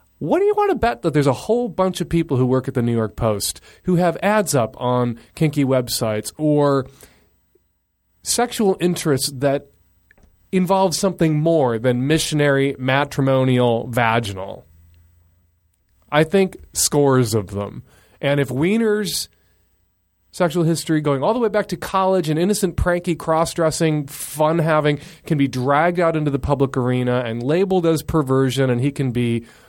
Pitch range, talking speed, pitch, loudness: 125-170 Hz, 155 wpm, 145 Hz, -19 LUFS